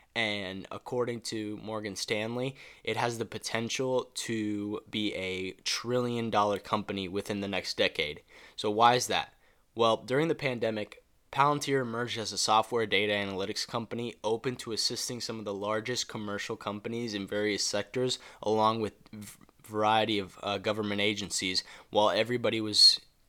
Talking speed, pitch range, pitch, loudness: 150 wpm, 105-120 Hz, 110 Hz, -30 LUFS